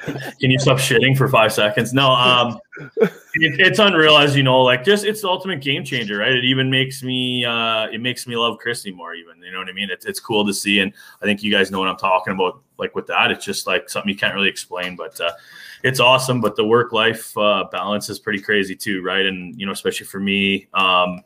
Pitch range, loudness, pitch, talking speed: 100-130 Hz, -17 LUFS, 115 Hz, 245 wpm